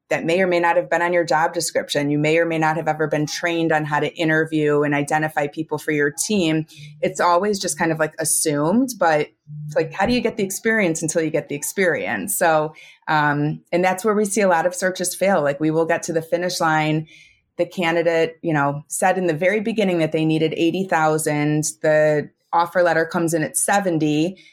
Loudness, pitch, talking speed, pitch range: -20 LUFS, 160 Hz, 225 wpm, 155-175 Hz